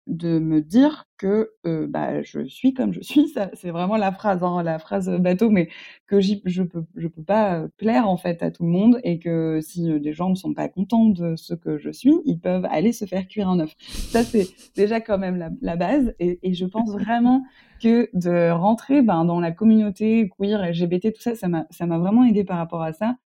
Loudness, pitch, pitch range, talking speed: -21 LUFS, 190 Hz, 170-225 Hz, 240 wpm